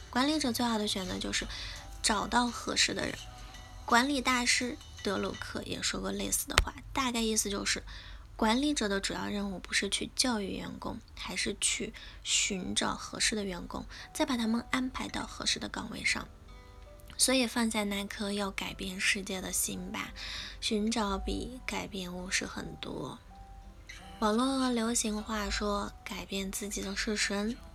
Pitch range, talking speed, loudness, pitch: 195-240 Hz, 240 characters per minute, -32 LUFS, 215 Hz